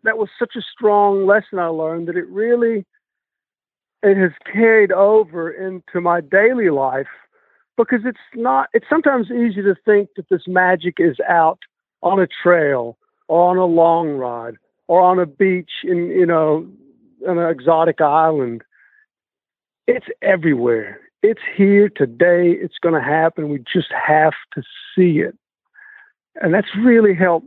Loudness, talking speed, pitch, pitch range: -16 LUFS, 150 wpm, 185 Hz, 165-220 Hz